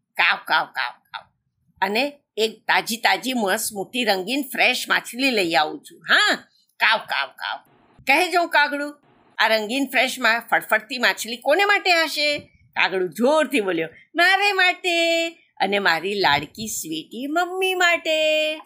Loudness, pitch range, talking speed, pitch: -20 LUFS, 220-335 Hz, 140 wpm, 275 Hz